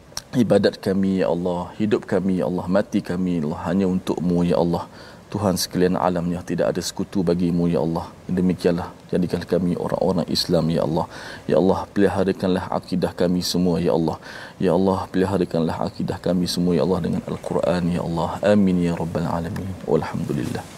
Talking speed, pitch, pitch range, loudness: 165 wpm, 90 Hz, 85-95 Hz, -22 LUFS